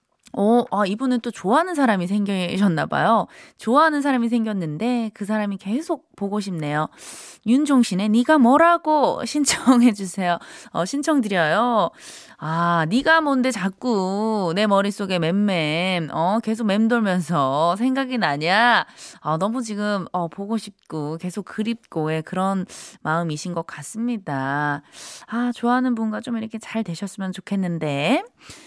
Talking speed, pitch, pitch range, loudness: 285 characters per minute, 210 Hz, 180-240 Hz, -21 LUFS